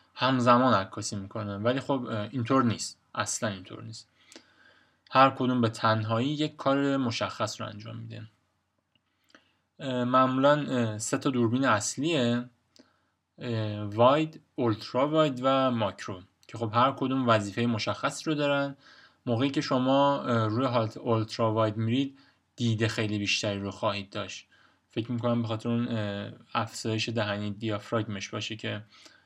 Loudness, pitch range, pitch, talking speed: -28 LUFS, 110-130 Hz, 115 Hz, 125 wpm